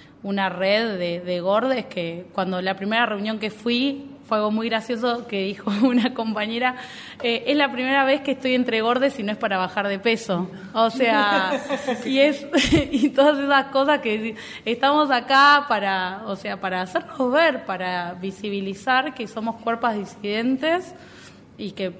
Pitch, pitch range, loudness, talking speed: 230 Hz, 200-270 Hz, -22 LUFS, 165 wpm